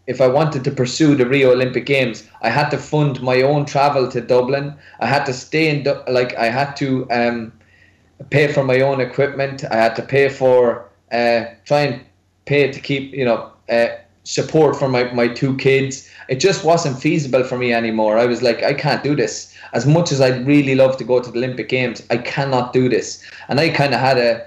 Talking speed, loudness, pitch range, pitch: 220 wpm, -17 LUFS, 120-140 Hz, 130 Hz